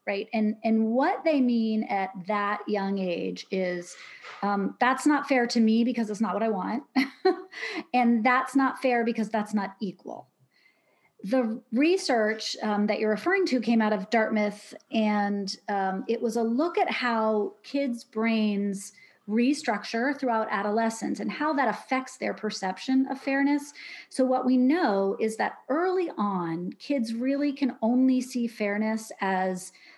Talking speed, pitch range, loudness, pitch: 155 wpm, 210-265 Hz, -27 LUFS, 230 Hz